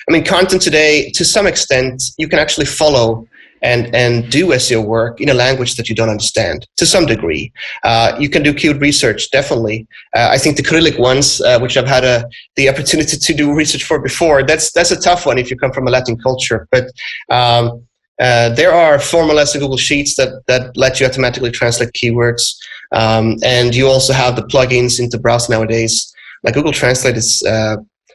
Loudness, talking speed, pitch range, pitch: -12 LUFS, 200 wpm, 120-145 Hz, 130 Hz